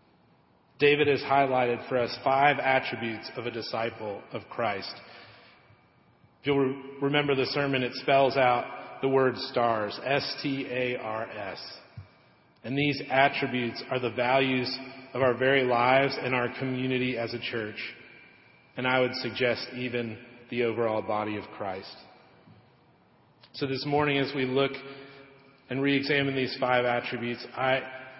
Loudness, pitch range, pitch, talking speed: -28 LUFS, 120-135 Hz, 130 Hz, 145 wpm